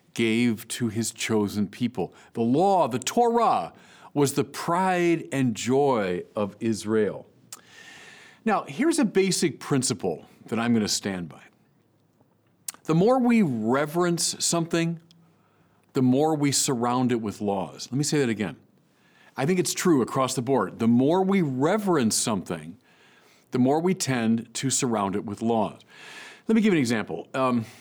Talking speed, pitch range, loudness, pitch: 155 wpm, 115-175 Hz, -24 LUFS, 135 Hz